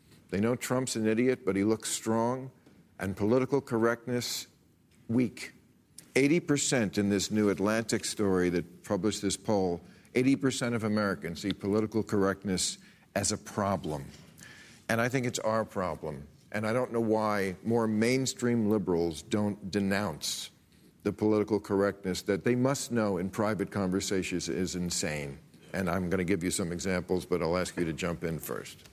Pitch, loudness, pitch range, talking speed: 105 Hz, -30 LUFS, 95-115 Hz, 160 wpm